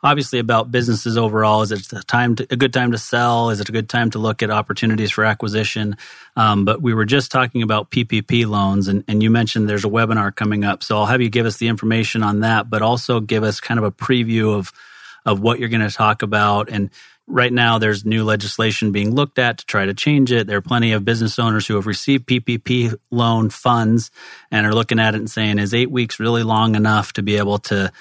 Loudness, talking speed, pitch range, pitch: -18 LUFS, 240 wpm, 105-120 Hz, 110 Hz